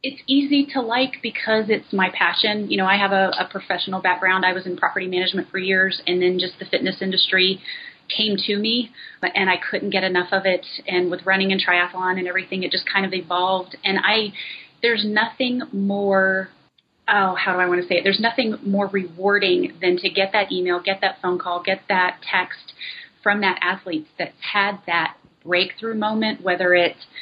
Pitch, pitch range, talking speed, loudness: 190 Hz, 185-210 Hz, 200 wpm, -20 LUFS